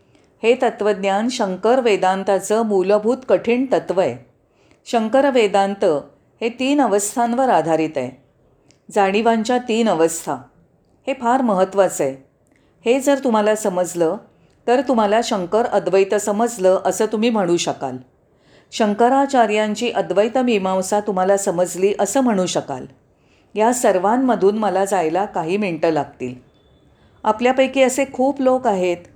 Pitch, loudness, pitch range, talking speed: 210 Hz, -18 LUFS, 185-235 Hz, 115 wpm